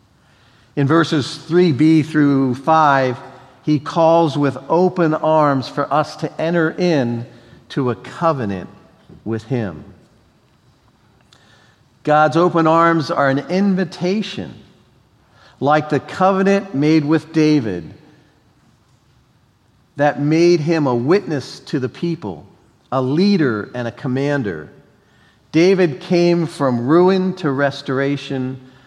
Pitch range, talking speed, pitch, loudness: 130-165 Hz, 105 wpm, 145 Hz, -17 LUFS